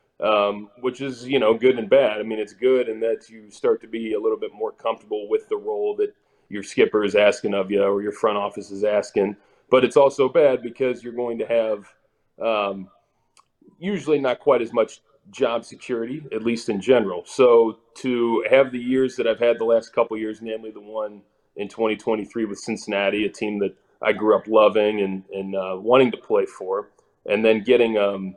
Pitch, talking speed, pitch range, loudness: 115 Hz, 205 wpm, 105-130 Hz, -22 LUFS